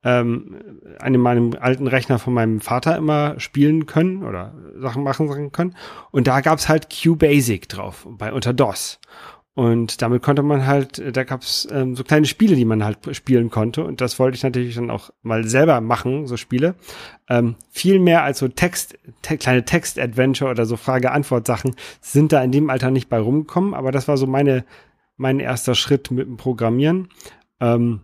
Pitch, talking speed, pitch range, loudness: 130 Hz, 180 wpm, 120-145 Hz, -19 LUFS